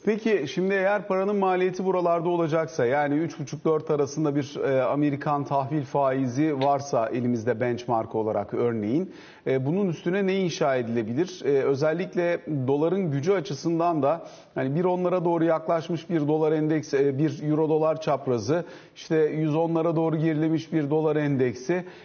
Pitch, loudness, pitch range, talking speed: 155 Hz, -25 LUFS, 140-175 Hz, 130 wpm